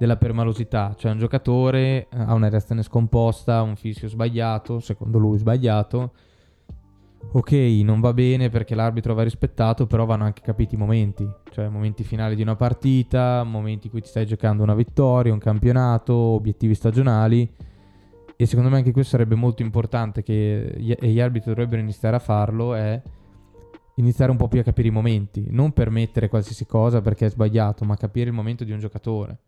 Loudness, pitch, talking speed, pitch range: -21 LUFS, 115 Hz, 175 wpm, 110-120 Hz